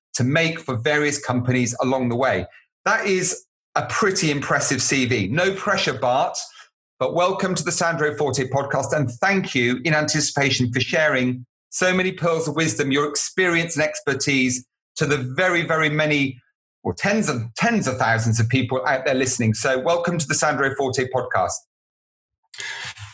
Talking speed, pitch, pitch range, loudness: 165 wpm, 145 Hz, 130-170 Hz, -21 LUFS